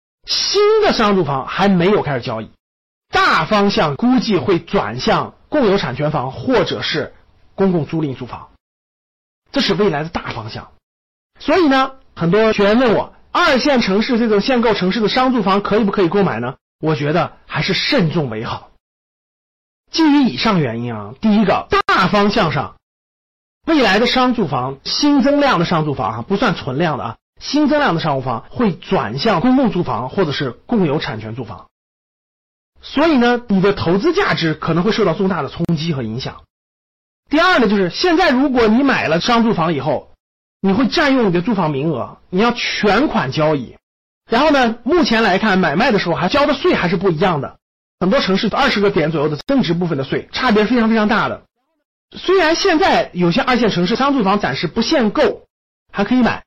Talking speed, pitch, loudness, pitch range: 280 characters per minute, 200 Hz, -16 LUFS, 165-255 Hz